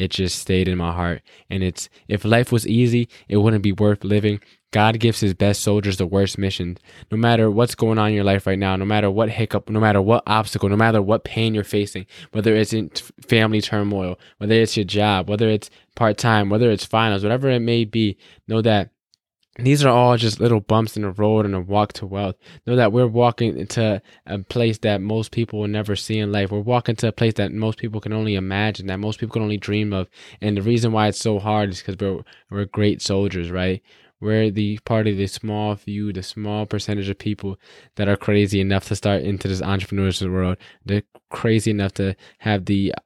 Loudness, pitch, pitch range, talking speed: -20 LUFS, 105 Hz, 100-110 Hz, 220 wpm